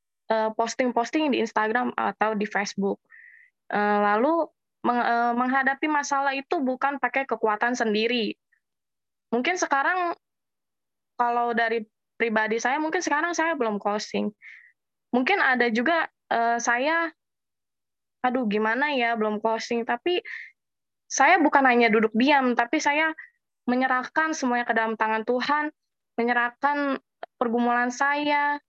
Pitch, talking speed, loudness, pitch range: 245 Hz, 105 wpm, -24 LUFS, 230-290 Hz